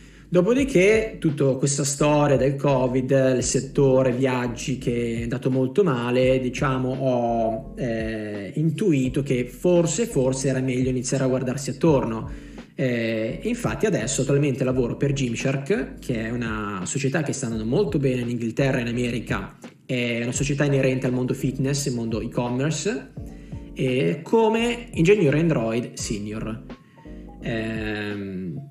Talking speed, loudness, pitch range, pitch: 135 wpm, -23 LUFS, 120-145 Hz, 130 Hz